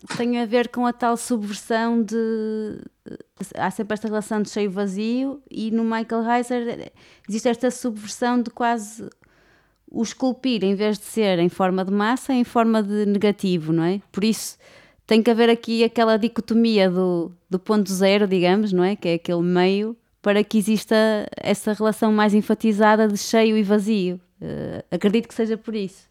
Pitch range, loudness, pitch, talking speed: 200-230 Hz, -21 LUFS, 220 Hz, 175 wpm